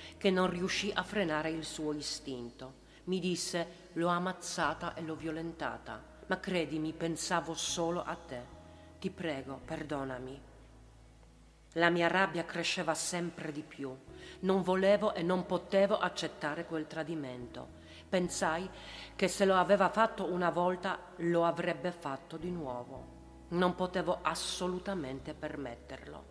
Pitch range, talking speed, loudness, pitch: 140-180 Hz, 130 wpm, -34 LUFS, 165 Hz